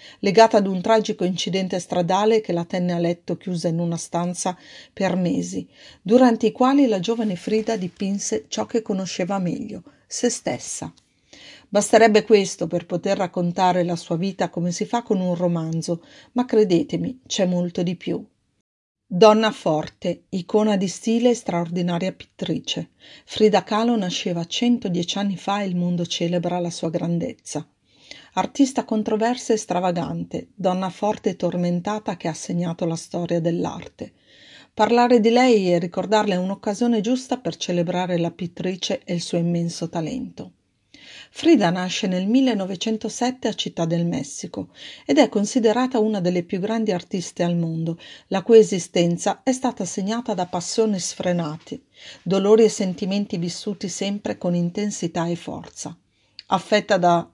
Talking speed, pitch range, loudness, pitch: 145 wpm, 175-220 Hz, -22 LUFS, 190 Hz